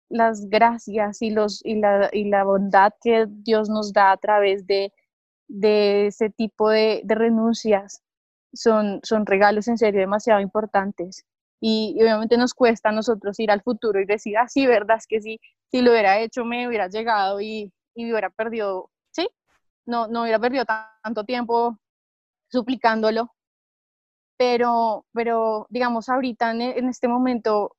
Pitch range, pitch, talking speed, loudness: 210-235 Hz, 220 Hz, 160 wpm, -21 LUFS